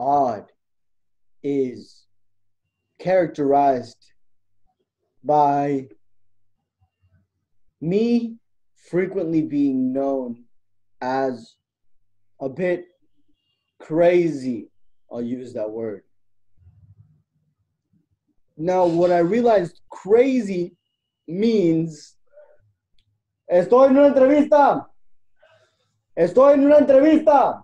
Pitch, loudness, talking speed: 135 Hz, -19 LUFS, 65 wpm